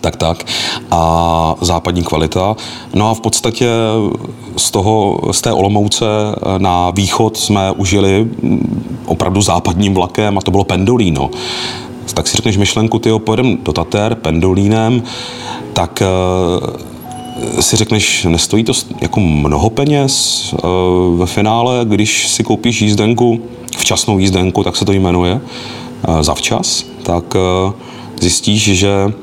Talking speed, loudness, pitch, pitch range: 125 wpm, -13 LUFS, 105 Hz, 90-115 Hz